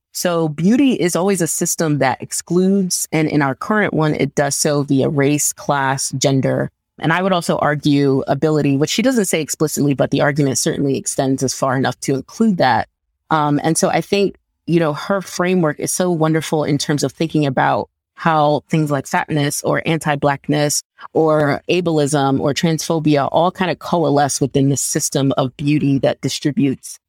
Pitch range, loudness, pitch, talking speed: 140-170 Hz, -17 LUFS, 150 Hz, 180 wpm